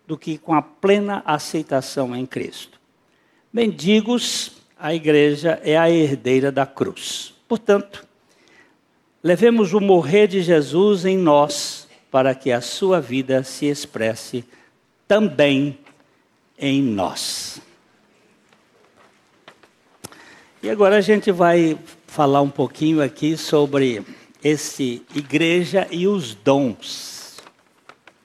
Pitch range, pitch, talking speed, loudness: 140-190 Hz, 155 Hz, 105 wpm, -19 LUFS